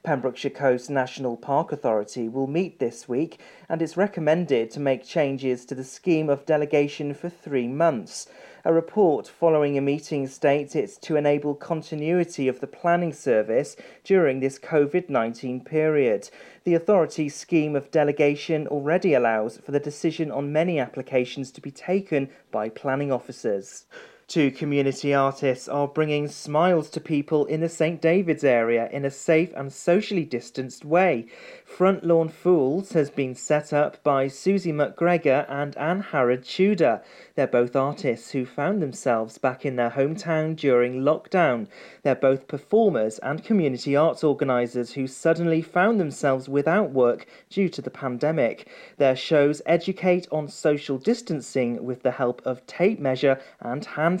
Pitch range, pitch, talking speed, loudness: 135-165 Hz, 145 Hz, 155 wpm, -24 LUFS